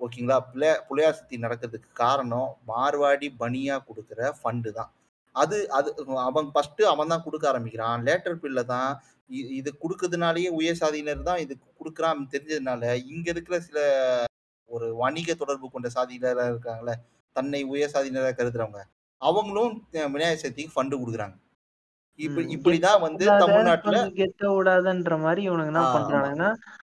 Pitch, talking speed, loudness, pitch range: 145 Hz, 125 wpm, -26 LUFS, 125-165 Hz